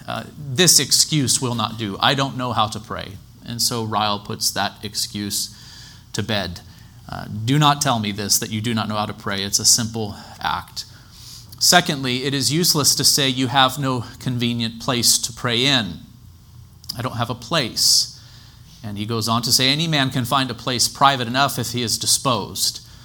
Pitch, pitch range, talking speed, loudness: 120 Hz, 110-130 Hz, 195 wpm, -18 LUFS